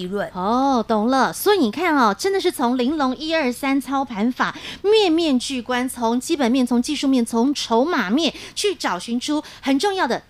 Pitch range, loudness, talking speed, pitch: 240-300 Hz, -20 LUFS, 270 characters per minute, 260 Hz